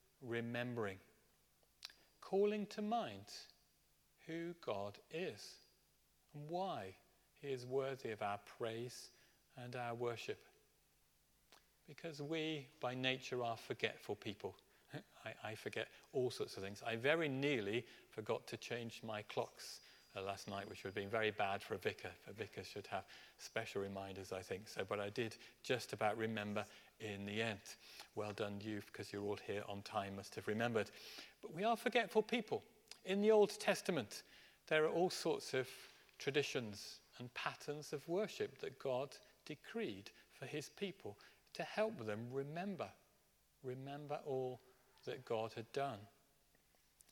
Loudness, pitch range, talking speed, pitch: -44 LUFS, 105-155 Hz, 150 wpm, 125 Hz